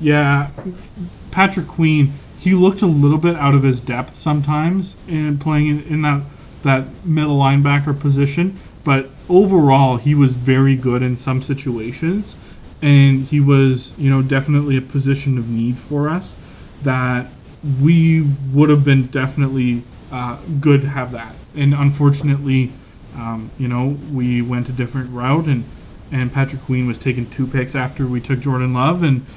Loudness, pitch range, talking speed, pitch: -17 LUFS, 130-150 Hz, 160 wpm, 140 Hz